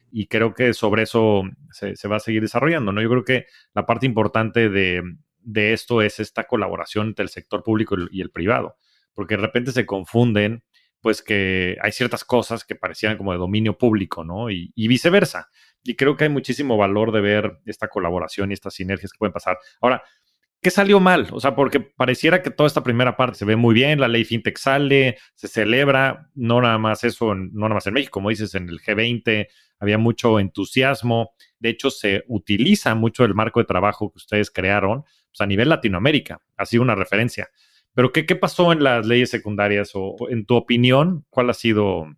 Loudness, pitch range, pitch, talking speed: -20 LUFS, 105-125 Hz, 110 Hz, 205 wpm